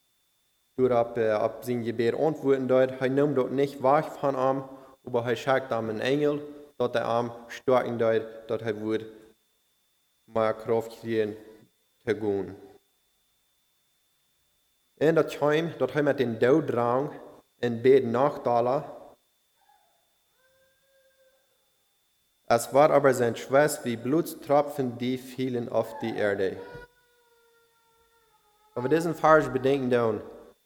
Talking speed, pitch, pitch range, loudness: 120 wpm, 130 Hz, 115-150 Hz, -26 LUFS